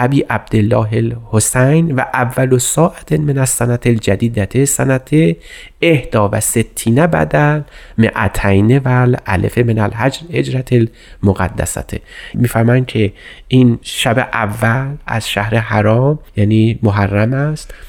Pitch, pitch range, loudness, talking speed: 120 Hz, 110-130 Hz, -14 LUFS, 115 wpm